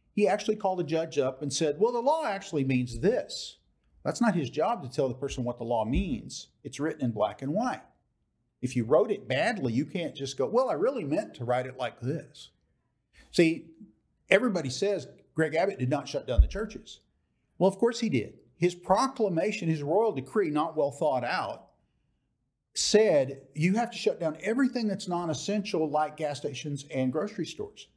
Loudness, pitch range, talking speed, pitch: -29 LUFS, 135-200 Hz, 195 wpm, 160 Hz